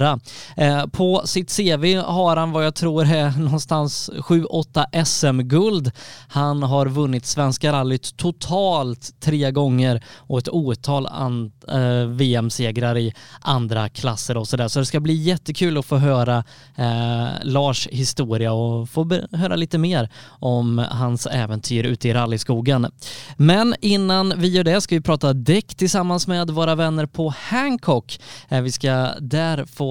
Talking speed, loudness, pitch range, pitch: 140 wpm, -20 LUFS, 125-165 Hz, 140 Hz